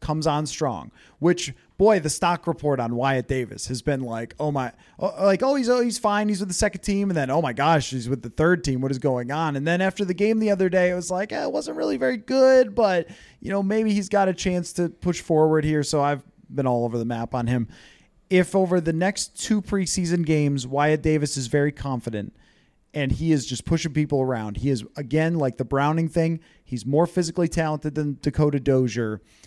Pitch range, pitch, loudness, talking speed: 135-185 Hz, 155 Hz, -23 LUFS, 230 wpm